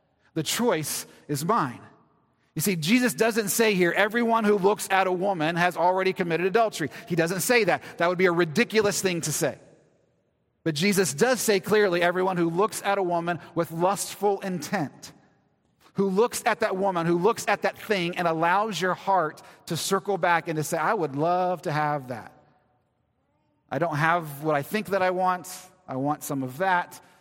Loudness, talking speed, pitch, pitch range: -25 LUFS, 190 wpm, 185 Hz, 165-200 Hz